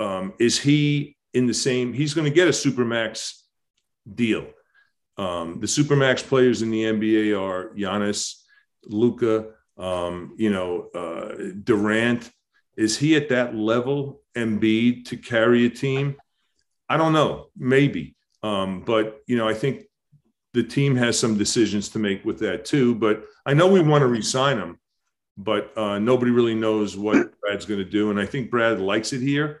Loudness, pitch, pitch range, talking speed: -22 LUFS, 115 Hz, 105-140 Hz, 170 wpm